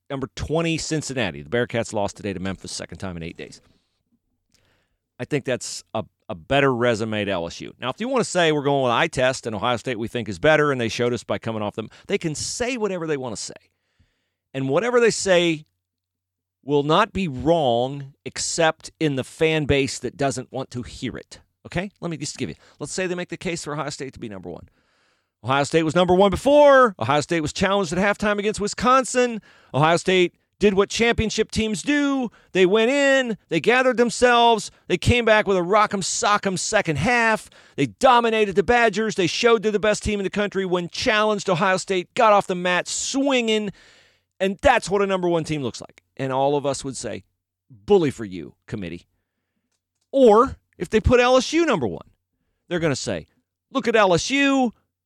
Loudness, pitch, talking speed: -21 LUFS, 160 Hz, 205 wpm